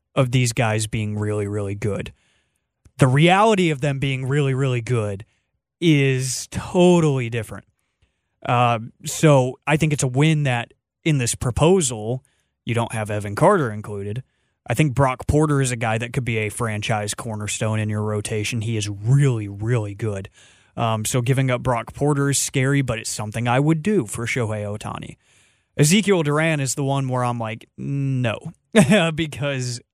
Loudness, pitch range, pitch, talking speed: -21 LUFS, 110-140 Hz, 125 Hz, 165 wpm